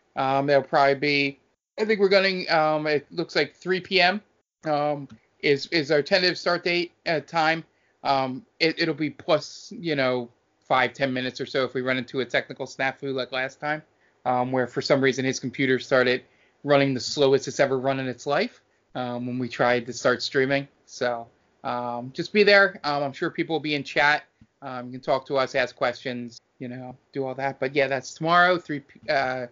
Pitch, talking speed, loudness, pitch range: 140 Hz, 210 wpm, -24 LUFS, 130-155 Hz